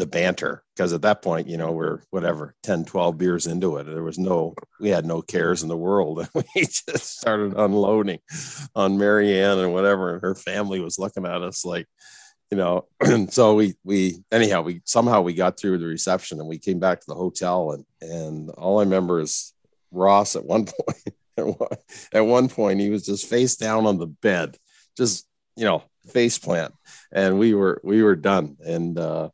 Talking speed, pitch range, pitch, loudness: 200 wpm, 85-105 Hz, 95 Hz, -22 LUFS